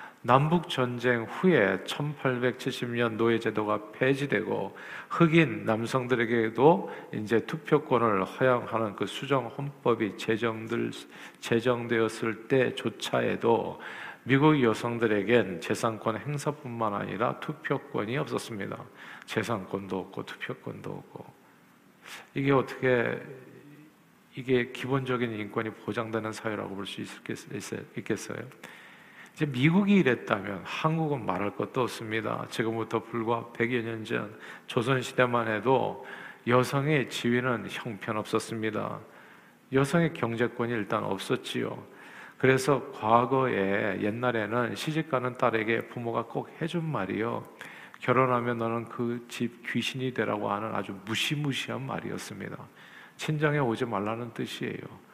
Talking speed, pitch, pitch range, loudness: 270 characters per minute, 120 Hz, 110-130 Hz, -29 LUFS